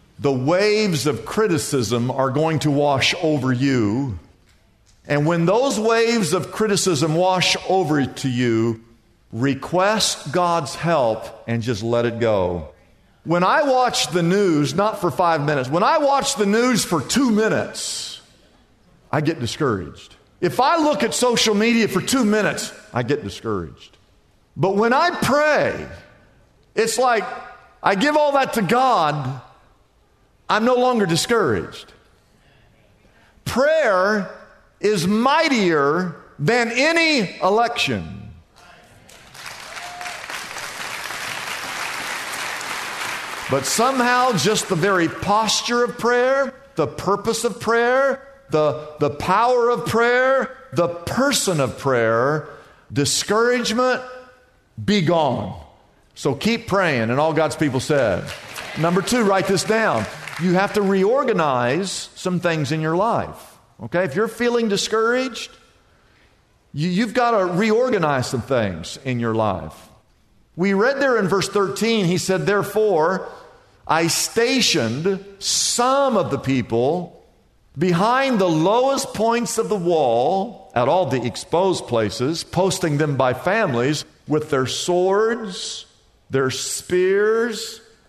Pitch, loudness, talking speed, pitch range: 185 Hz, -19 LUFS, 120 wpm, 140-230 Hz